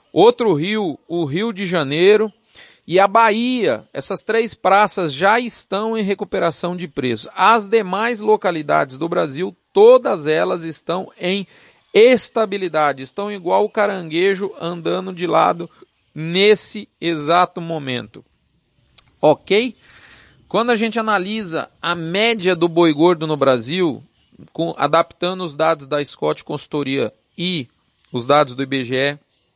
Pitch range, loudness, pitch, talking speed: 160-210 Hz, -18 LUFS, 180 Hz, 125 wpm